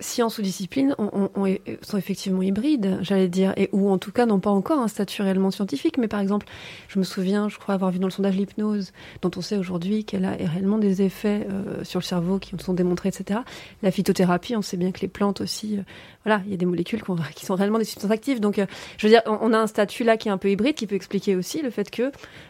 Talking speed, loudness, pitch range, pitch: 270 wpm, -24 LUFS, 190-215 Hz, 200 Hz